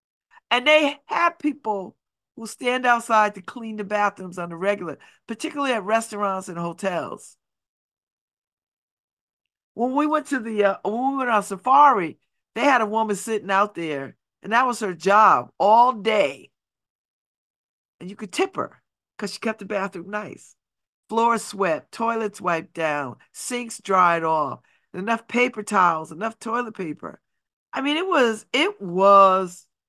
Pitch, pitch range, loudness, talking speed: 215 Hz, 195-245 Hz, -22 LUFS, 155 wpm